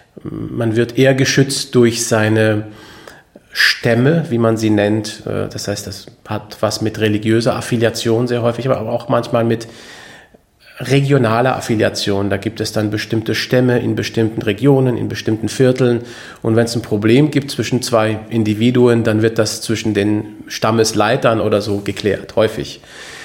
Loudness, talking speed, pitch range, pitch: -16 LUFS, 150 wpm, 110-120 Hz, 115 Hz